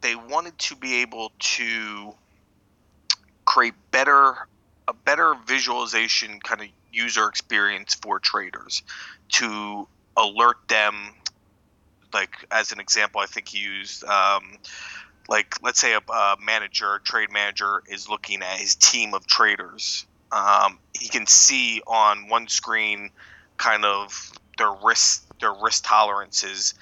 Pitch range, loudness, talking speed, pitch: 100-120 Hz, -21 LUFS, 130 wpm, 105 Hz